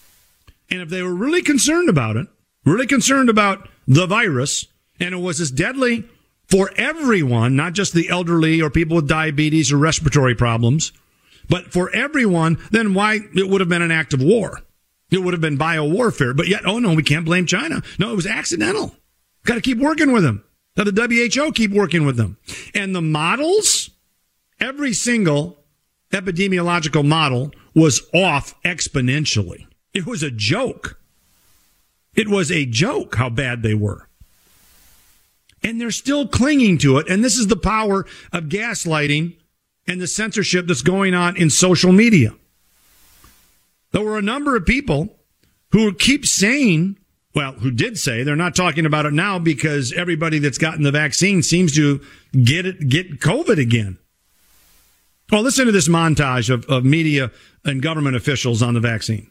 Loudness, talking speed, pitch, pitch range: -17 LUFS, 165 wpm, 170 Hz, 145-205 Hz